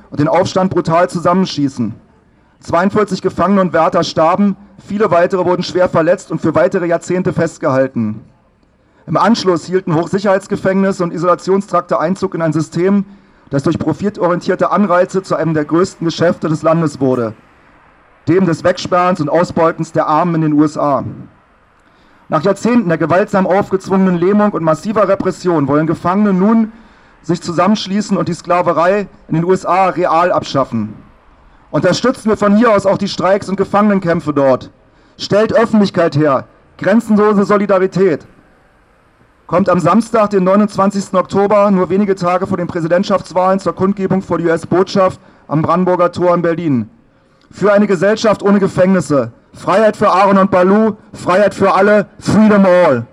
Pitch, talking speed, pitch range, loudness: 180 Hz, 145 wpm, 165-195 Hz, -13 LUFS